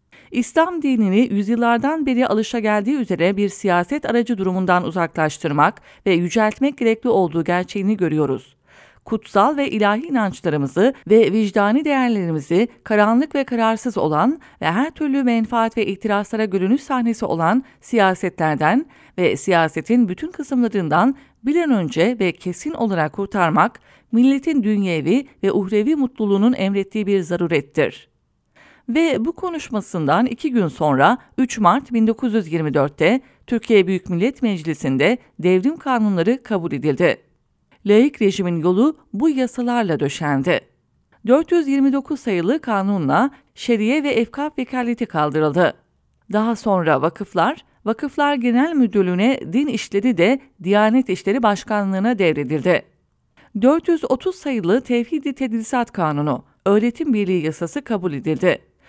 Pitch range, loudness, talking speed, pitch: 185-255 Hz, -19 LUFS, 115 wpm, 220 Hz